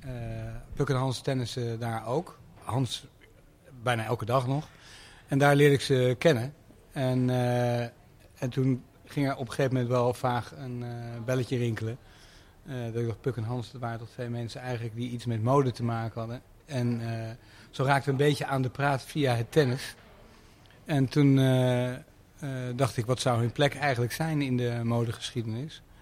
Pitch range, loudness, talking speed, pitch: 120-135 Hz, -29 LUFS, 190 wpm, 125 Hz